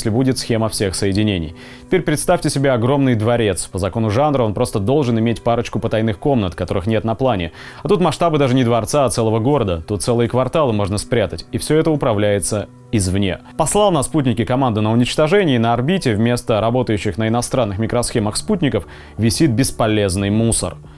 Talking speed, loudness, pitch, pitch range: 175 wpm, -17 LUFS, 120 Hz, 105-135 Hz